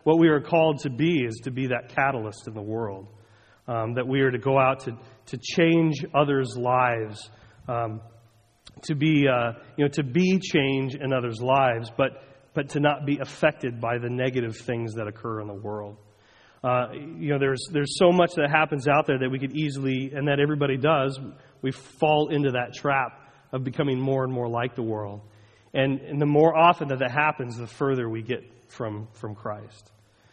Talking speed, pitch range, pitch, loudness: 200 wpm, 115-145 Hz, 130 Hz, -25 LUFS